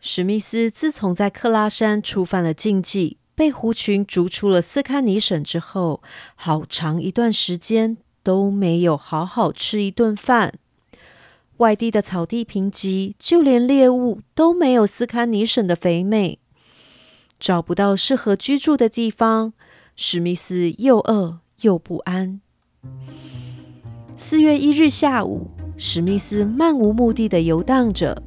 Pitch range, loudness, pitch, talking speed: 175-230 Hz, -19 LUFS, 205 Hz, 205 characters per minute